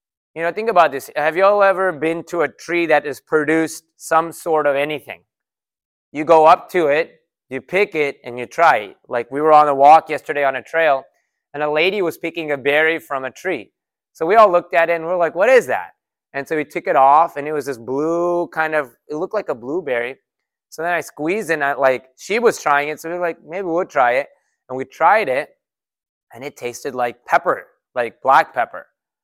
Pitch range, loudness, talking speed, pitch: 140-170 Hz, -17 LUFS, 235 wpm, 155 Hz